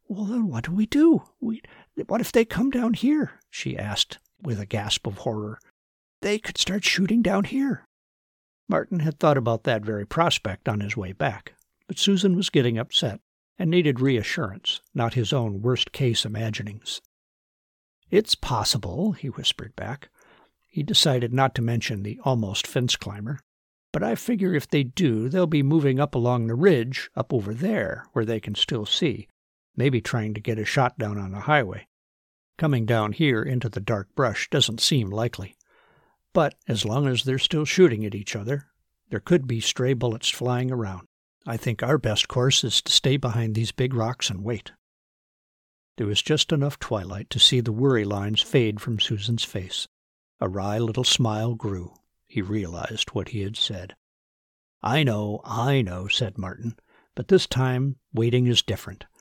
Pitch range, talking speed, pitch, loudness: 105-145 Hz, 175 wpm, 120 Hz, -24 LUFS